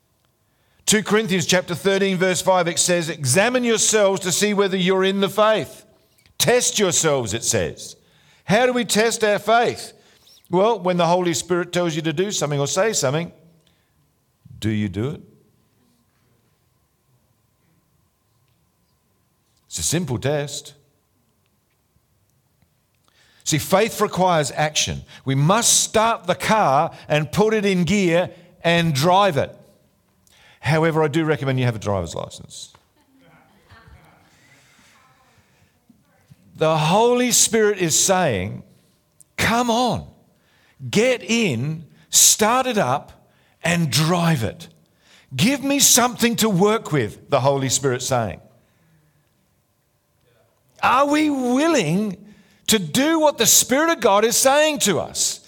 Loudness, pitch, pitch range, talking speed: -18 LUFS, 175 Hz, 140-210 Hz, 120 wpm